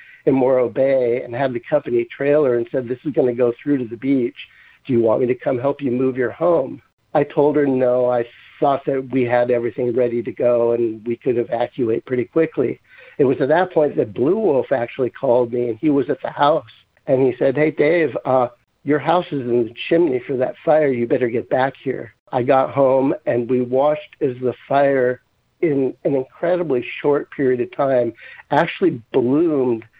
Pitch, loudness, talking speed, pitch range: 130 Hz, -19 LUFS, 210 wpm, 120-145 Hz